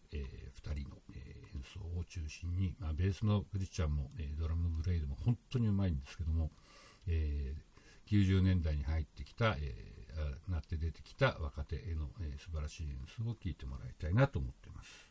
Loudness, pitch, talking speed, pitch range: -38 LUFS, 80 Hz, 385 characters per minute, 75-95 Hz